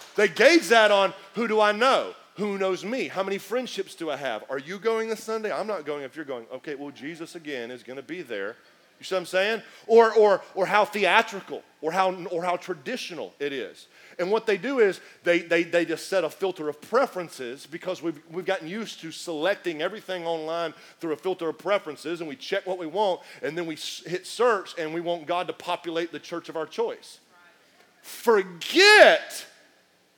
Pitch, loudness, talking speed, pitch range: 185 Hz, -25 LUFS, 210 wpm, 165-220 Hz